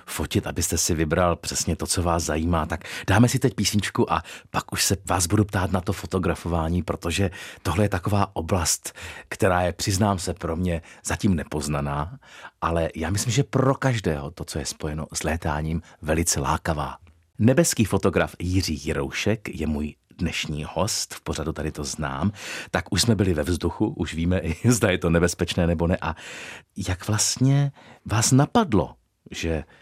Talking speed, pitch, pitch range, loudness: 170 wpm, 90 Hz, 80-100 Hz, -24 LUFS